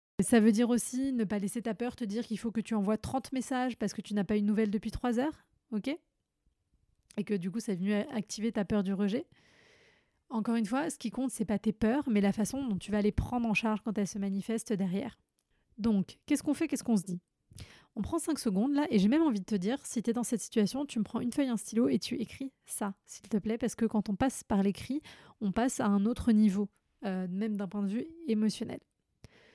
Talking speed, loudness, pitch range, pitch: 260 wpm, -32 LUFS, 205-245 Hz, 220 Hz